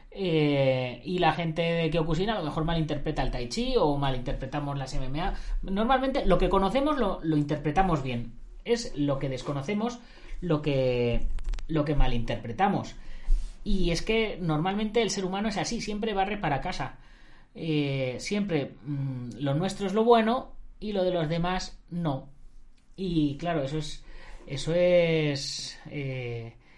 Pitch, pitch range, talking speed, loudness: 160 Hz, 135-190 Hz, 150 wpm, -28 LUFS